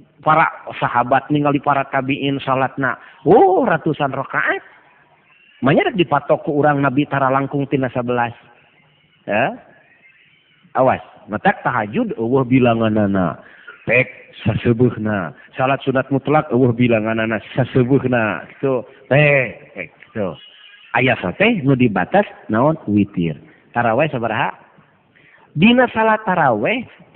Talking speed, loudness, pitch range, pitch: 135 wpm, -17 LUFS, 120-150 Hz, 135 Hz